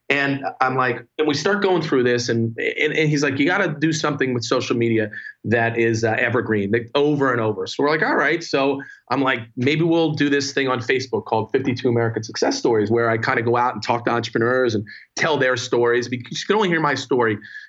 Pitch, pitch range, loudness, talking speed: 130 Hz, 115-145 Hz, -20 LUFS, 240 wpm